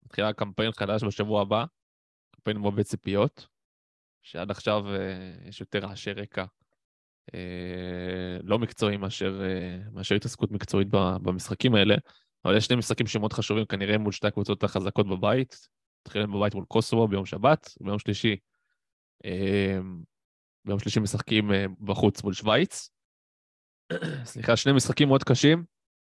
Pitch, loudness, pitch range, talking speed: 100 Hz, -27 LUFS, 95-110 Hz, 130 wpm